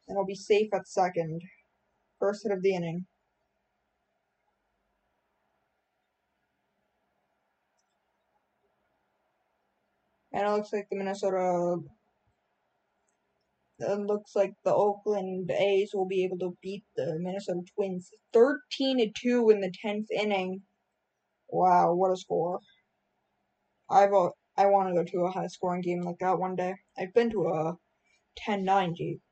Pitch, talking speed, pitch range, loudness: 195 Hz, 125 wpm, 180-205 Hz, -29 LUFS